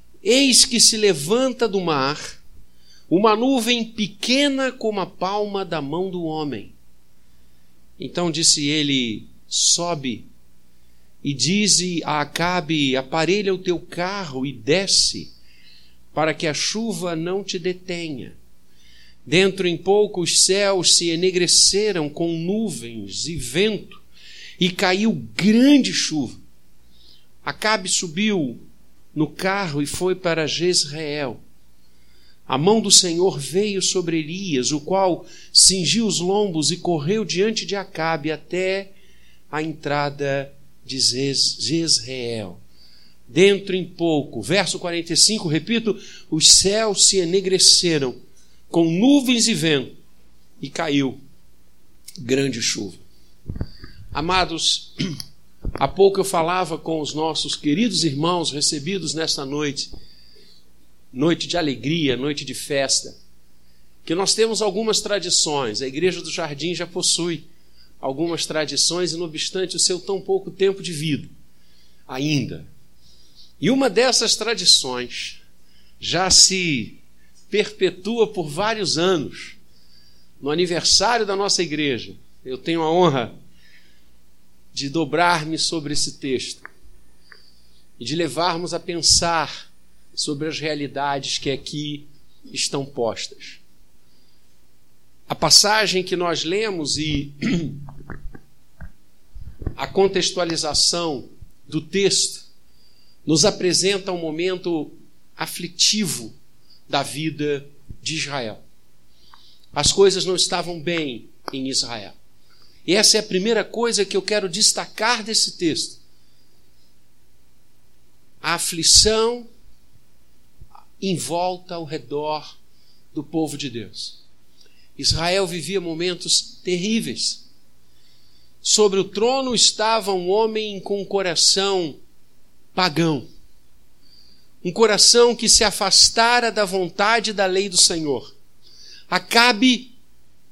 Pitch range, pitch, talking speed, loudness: 125-190 Hz, 160 Hz, 110 wpm, -19 LUFS